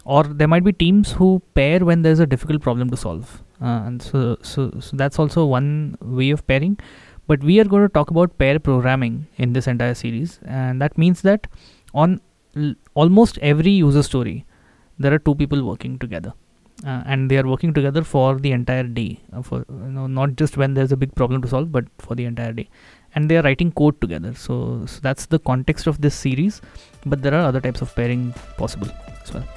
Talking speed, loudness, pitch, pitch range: 215 wpm, -19 LUFS, 135 Hz, 125-155 Hz